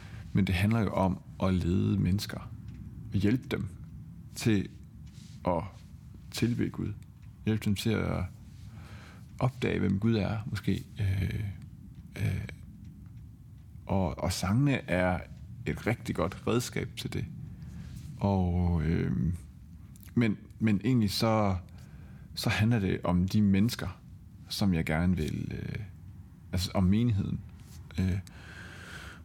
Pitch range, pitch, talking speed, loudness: 90-110 Hz, 100 Hz, 115 wpm, -31 LUFS